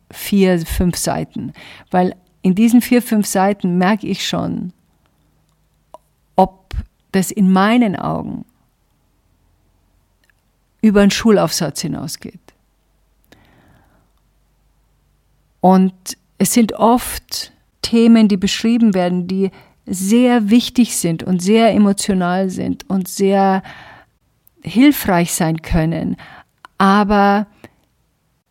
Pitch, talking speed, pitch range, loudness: 190 Hz, 90 wpm, 180-215 Hz, -15 LUFS